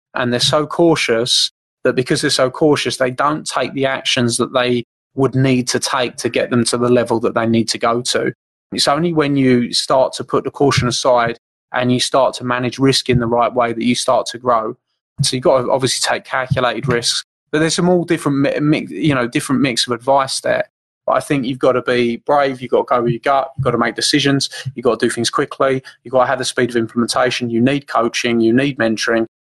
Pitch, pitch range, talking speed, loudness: 125 Hz, 120-140 Hz, 240 wpm, -16 LUFS